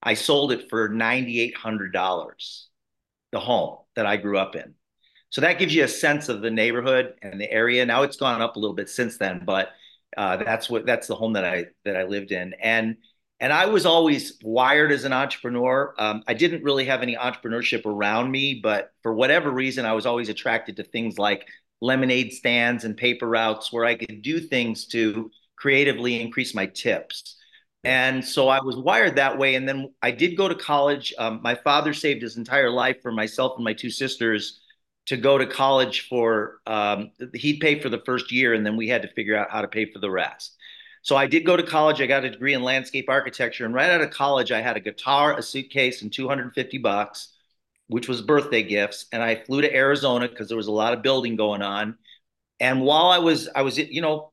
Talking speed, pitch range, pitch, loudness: 215 wpm, 110-135 Hz, 125 Hz, -22 LUFS